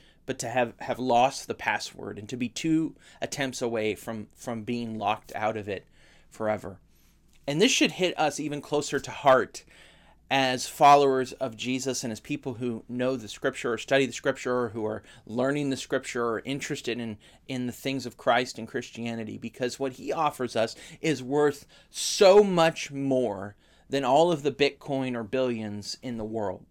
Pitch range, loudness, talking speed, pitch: 115-140 Hz, -27 LUFS, 180 wpm, 130 Hz